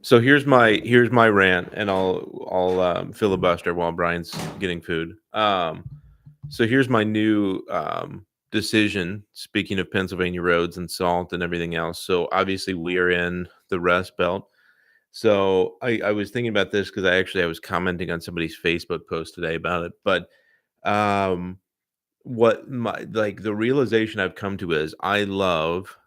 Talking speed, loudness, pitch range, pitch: 165 wpm, -22 LUFS, 90-110 Hz, 95 Hz